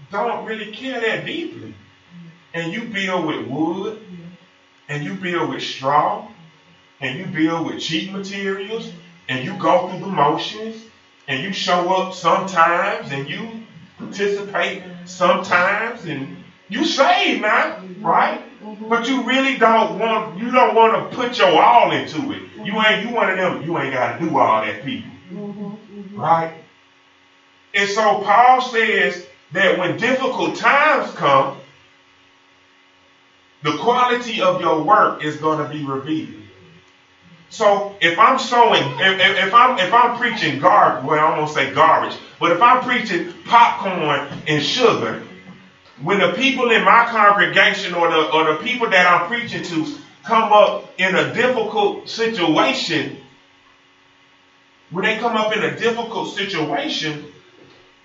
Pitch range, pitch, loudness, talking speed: 155-225 Hz, 185 Hz, -17 LUFS, 150 wpm